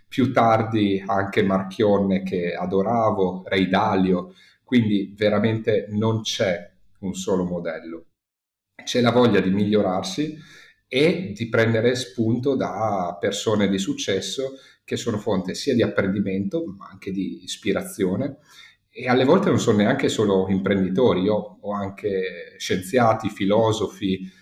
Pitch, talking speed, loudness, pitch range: 100 Hz, 125 wpm, -22 LUFS, 95-115 Hz